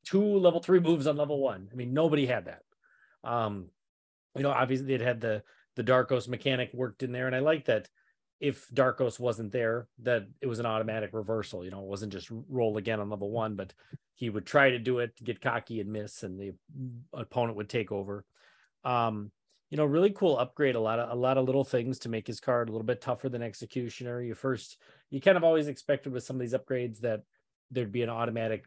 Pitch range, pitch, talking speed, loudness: 110-130 Hz, 120 Hz, 225 wpm, -30 LUFS